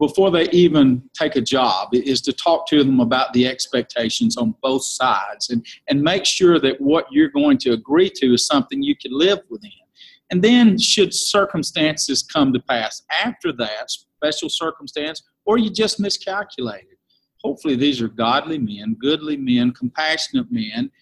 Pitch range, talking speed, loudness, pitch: 135-220 Hz, 165 wpm, -18 LUFS, 170 Hz